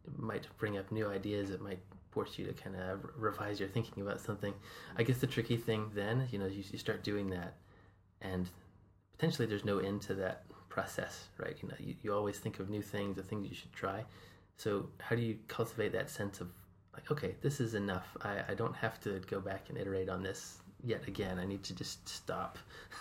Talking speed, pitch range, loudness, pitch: 225 wpm, 95-110 Hz, -40 LUFS, 100 Hz